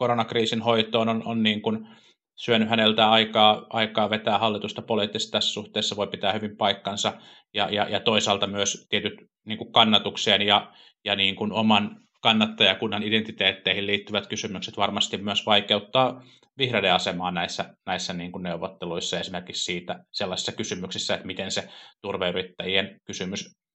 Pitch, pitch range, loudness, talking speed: 110 Hz, 100-115 Hz, -24 LUFS, 140 wpm